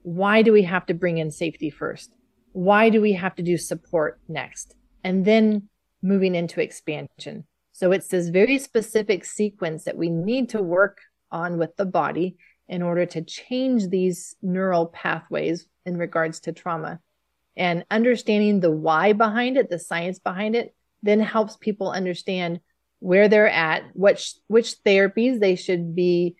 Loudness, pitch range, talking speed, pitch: -22 LUFS, 175-210 Hz, 160 wpm, 185 Hz